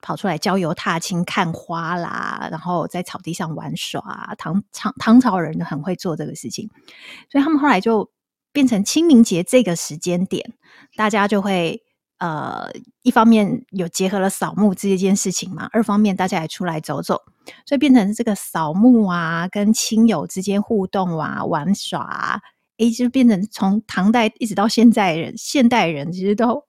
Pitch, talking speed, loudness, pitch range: 200 Hz, 265 characters per minute, -19 LUFS, 180-230 Hz